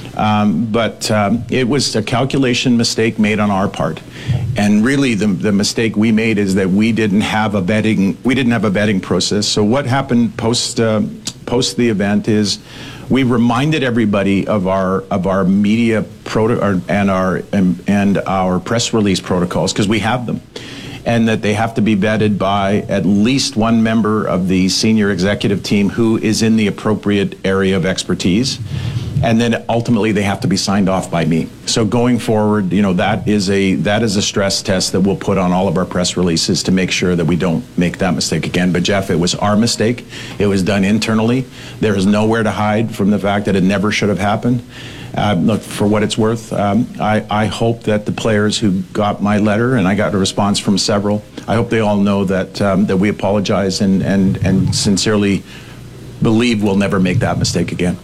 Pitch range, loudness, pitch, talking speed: 100-115 Hz, -15 LUFS, 105 Hz, 205 wpm